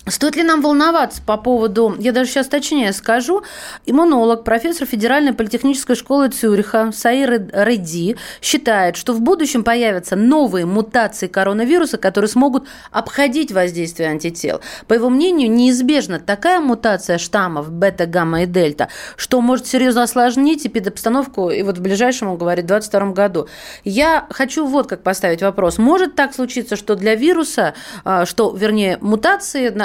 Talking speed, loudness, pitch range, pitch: 145 wpm, -16 LUFS, 195-275 Hz, 230 Hz